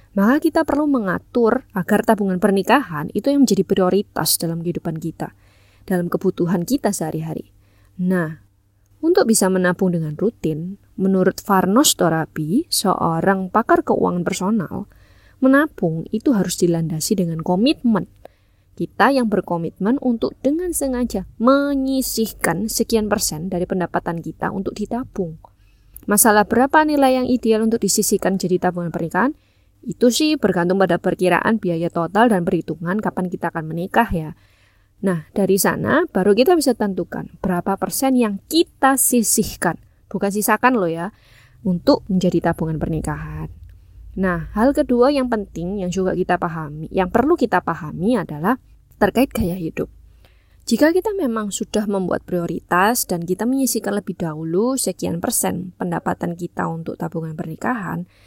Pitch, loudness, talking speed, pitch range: 190 Hz, -19 LUFS, 135 wpm, 170-230 Hz